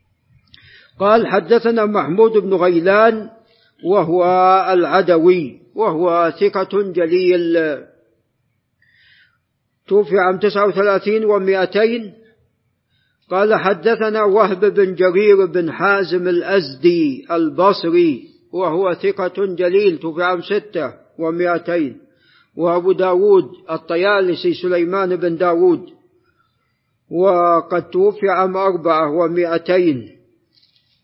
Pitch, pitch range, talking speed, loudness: 185 Hz, 175-205 Hz, 80 wpm, -16 LUFS